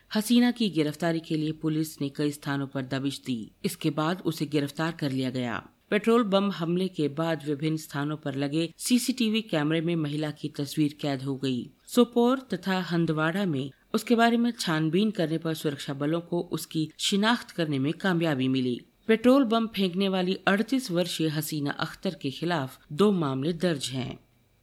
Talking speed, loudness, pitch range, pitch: 170 wpm, -27 LUFS, 145-195 Hz, 160 Hz